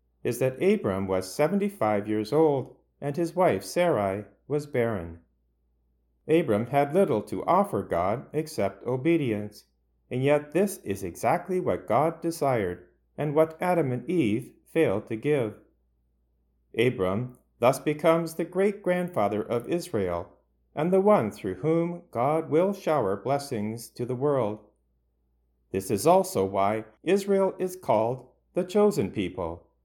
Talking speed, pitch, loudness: 135 wpm, 125 Hz, -27 LUFS